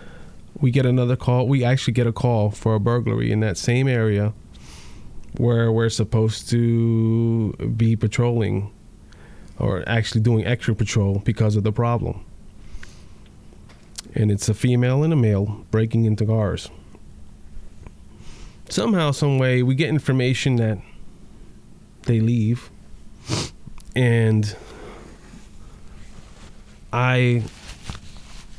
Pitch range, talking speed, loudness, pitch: 105-125 Hz, 105 wpm, -21 LUFS, 115 Hz